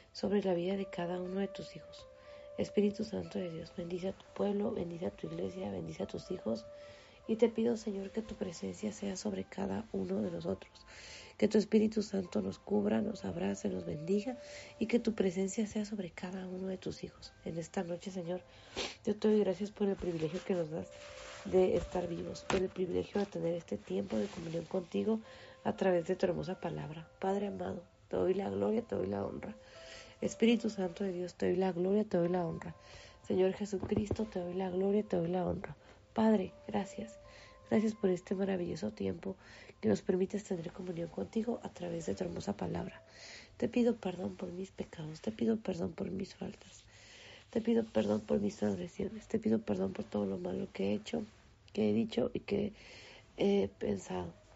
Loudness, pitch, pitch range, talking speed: -36 LUFS, 185 Hz, 160-205 Hz, 195 wpm